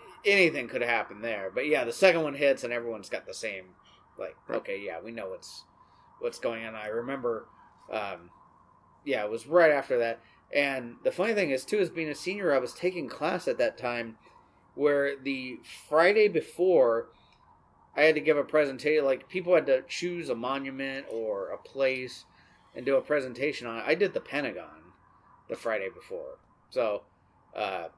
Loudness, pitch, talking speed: -29 LUFS, 170 Hz, 180 wpm